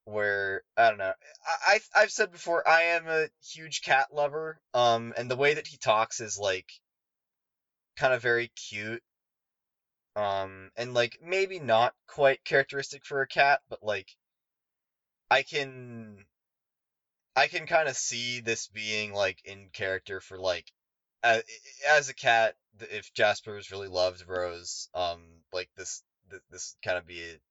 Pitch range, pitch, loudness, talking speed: 100-145 Hz, 115 Hz, -28 LUFS, 160 wpm